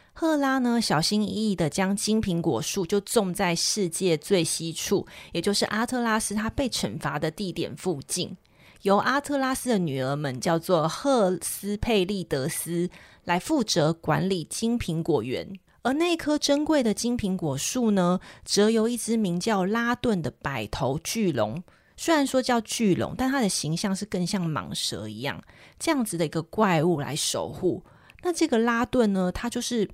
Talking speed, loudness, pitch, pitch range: 250 characters per minute, -26 LUFS, 200 Hz, 170-235 Hz